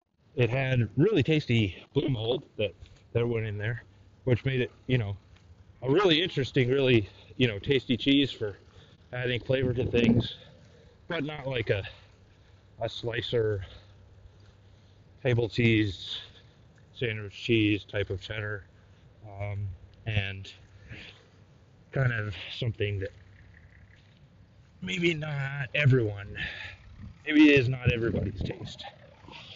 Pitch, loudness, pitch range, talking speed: 110 Hz, -28 LUFS, 100-125 Hz, 115 wpm